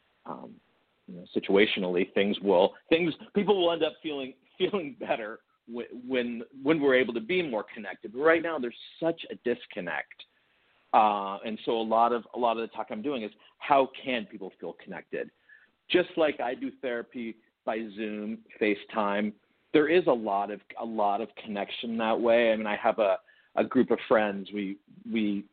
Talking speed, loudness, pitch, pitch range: 190 wpm, -28 LUFS, 120 Hz, 110-145 Hz